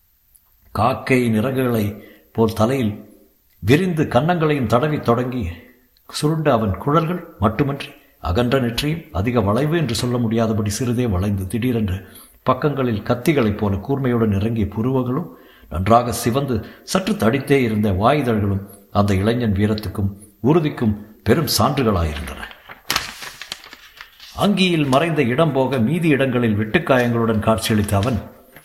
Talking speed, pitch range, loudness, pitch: 105 wpm, 105-135 Hz, -19 LUFS, 115 Hz